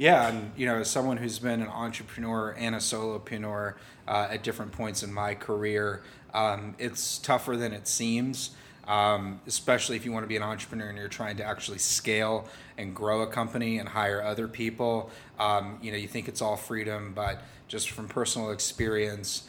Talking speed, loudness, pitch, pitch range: 190 wpm, -30 LUFS, 110 Hz, 105-120 Hz